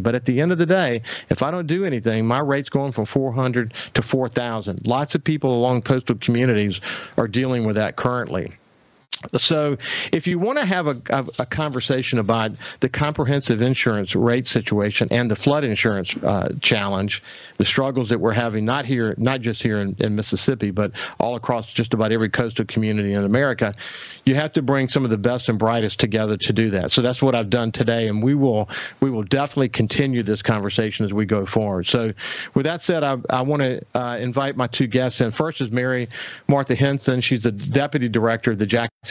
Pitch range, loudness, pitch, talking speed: 110-135 Hz, -21 LUFS, 120 Hz, 205 wpm